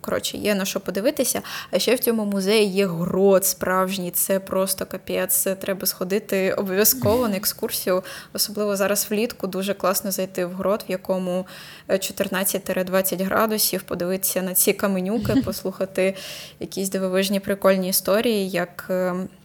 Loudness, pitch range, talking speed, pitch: -22 LUFS, 185-200 Hz, 135 wpm, 190 Hz